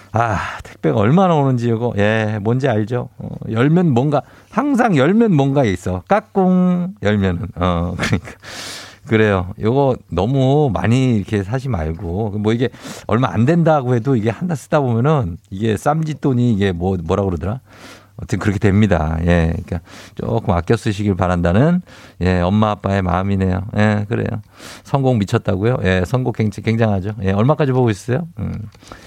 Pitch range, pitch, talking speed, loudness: 100-135 Hz, 110 Hz, 330 characters per minute, -17 LUFS